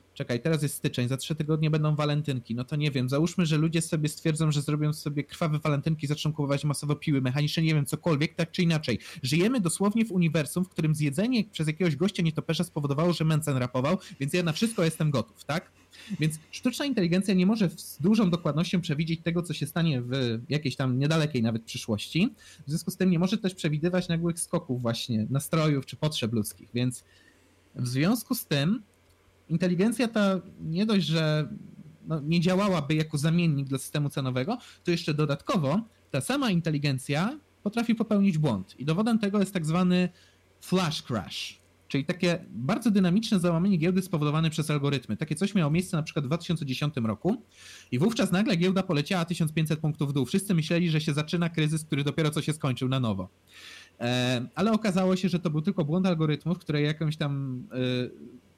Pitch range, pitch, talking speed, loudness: 140-180 Hz, 160 Hz, 180 wpm, -28 LUFS